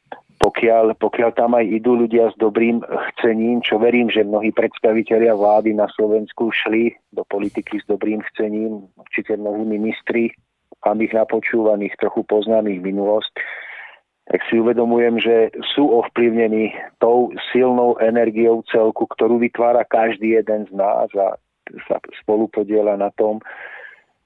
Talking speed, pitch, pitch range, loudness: 130 wpm, 110 Hz, 110-115 Hz, -18 LUFS